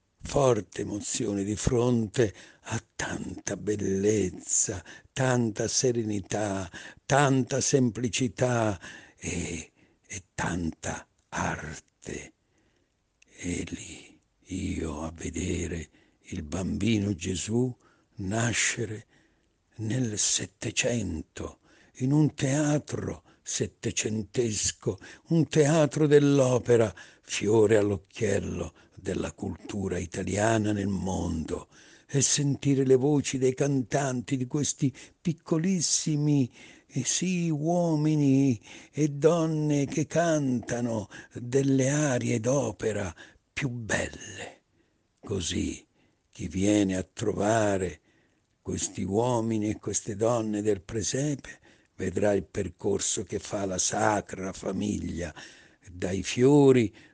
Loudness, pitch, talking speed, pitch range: -28 LUFS, 115 Hz, 85 wpm, 100-135 Hz